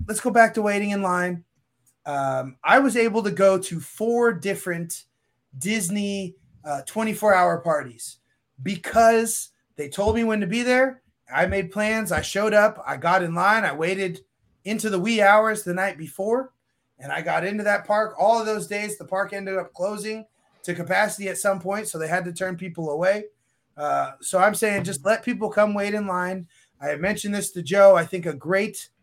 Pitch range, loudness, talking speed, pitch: 170-215 Hz, -22 LUFS, 200 wpm, 195 Hz